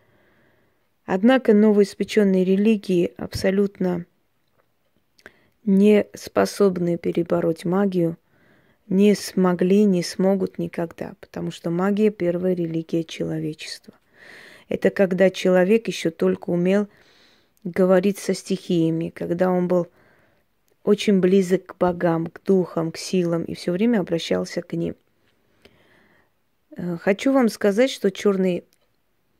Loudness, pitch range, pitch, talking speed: -21 LUFS, 175-200 Hz, 185 Hz, 100 wpm